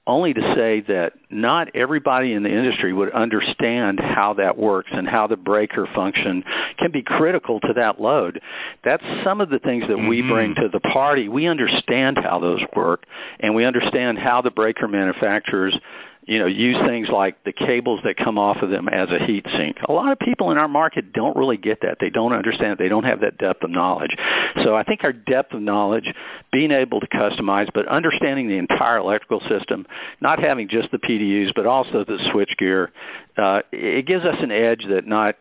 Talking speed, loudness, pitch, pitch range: 205 wpm, -20 LUFS, 110 Hz, 100-115 Hz